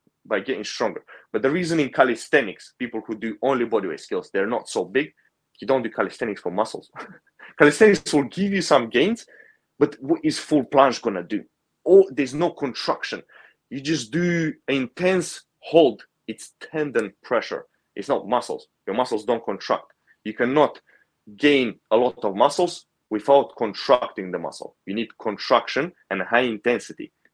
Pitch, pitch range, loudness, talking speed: 145 Hz, 120-180 Hz, -22 LUFS, 160 wpm